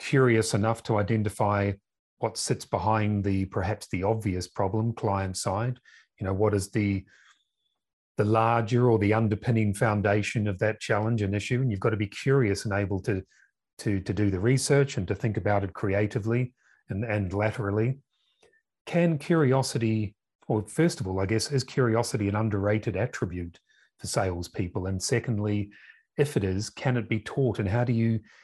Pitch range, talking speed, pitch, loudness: 100-120 Hz, 170 wpm, 110 Hz, -27 LUFS